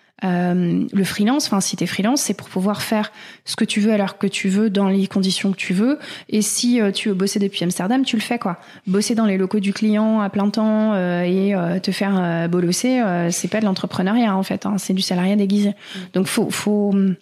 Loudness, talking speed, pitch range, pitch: -19 LUFS, 235 wpm, 190-215 Hz, 200 Hz